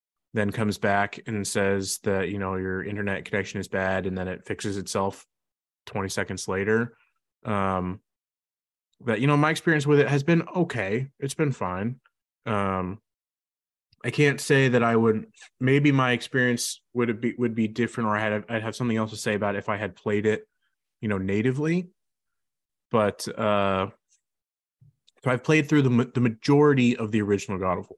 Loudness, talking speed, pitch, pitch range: -25 LUFS, 180 wpm, 110 Hz, 100-125 Hz